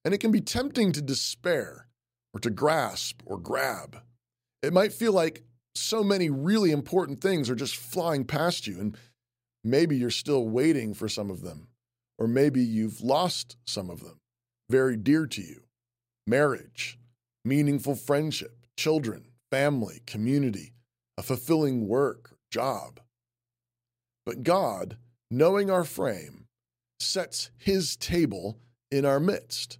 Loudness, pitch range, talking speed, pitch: -27 LUFS, 120-155 Hz, 135 wpm, 125 Hz